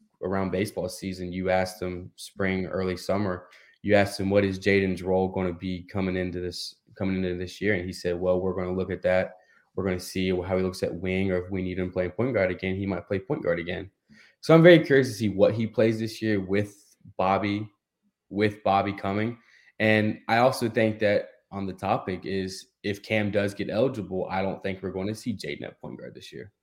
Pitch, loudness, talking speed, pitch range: 95 Hz, -26 LUFS, 230 wpm, 95-105 Hz